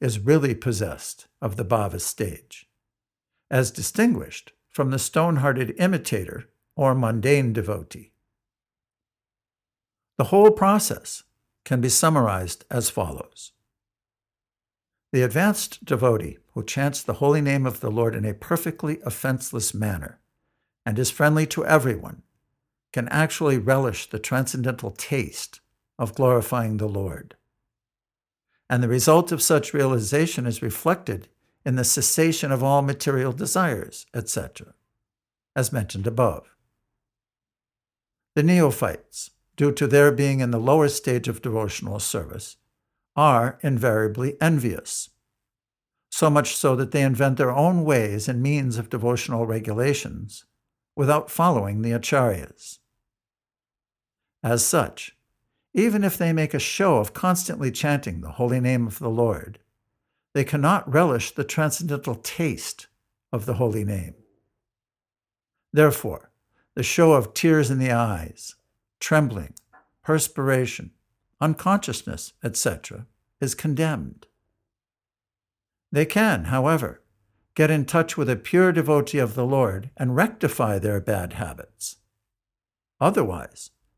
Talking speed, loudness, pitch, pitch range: 120 wpm, -22 LUFS, 125 Hz, 110-145 Hz